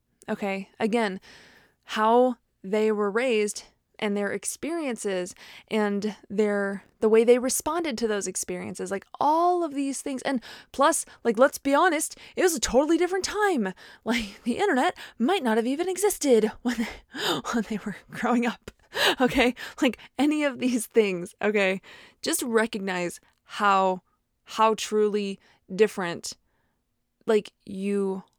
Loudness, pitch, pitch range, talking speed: -25 LUFS, 220 Hz, 200-260 Hz, 135 wpm